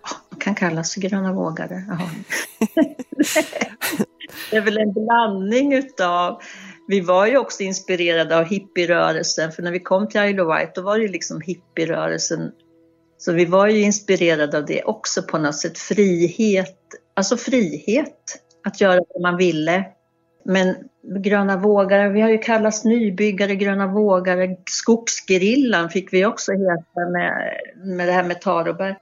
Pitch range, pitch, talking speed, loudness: 175-210 Hz, 190 Hz, 150 wpm, -19 LUFS